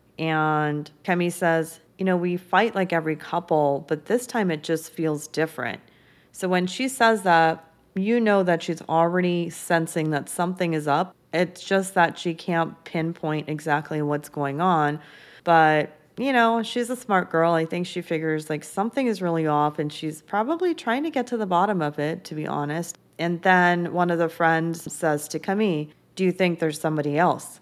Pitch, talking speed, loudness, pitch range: 170 Hz, 190 wpm, -24 LUFS, 155-185 Hz